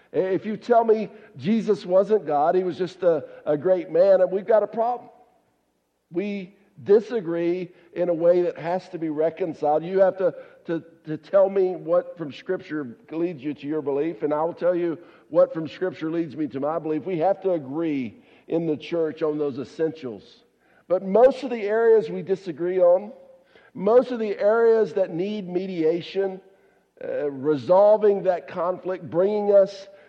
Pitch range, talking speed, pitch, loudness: 160-205 Hz, 175 wpm, 180 Hz, -23 LUFS